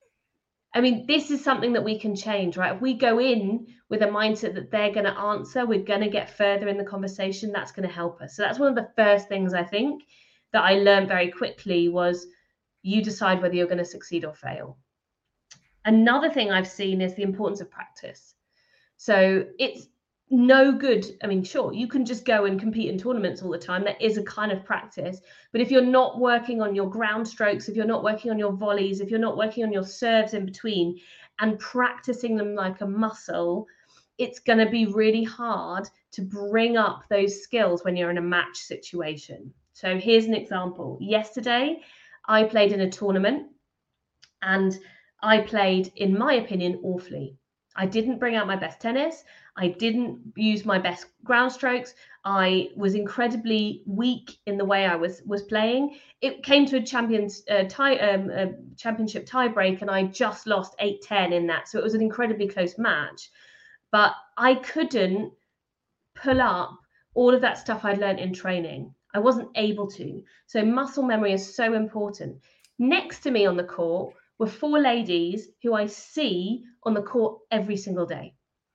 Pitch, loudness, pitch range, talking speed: 210 Hz, -24 LUFS, 195-240 Hz, 190 wpm